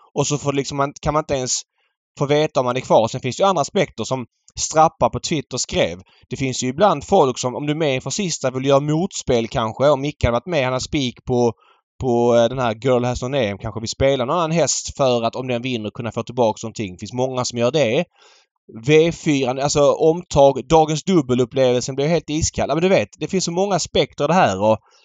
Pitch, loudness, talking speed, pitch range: 130 Hz, -19 LUFS, 230 wpm, 120-150 Hz